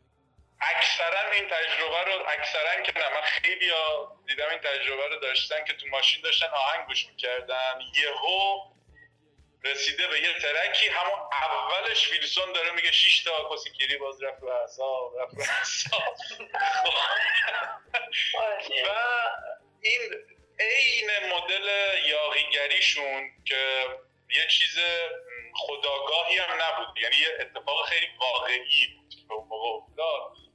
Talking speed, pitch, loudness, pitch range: 110 wpm, 160 Hz, -25 LUFS, 135-210 Hz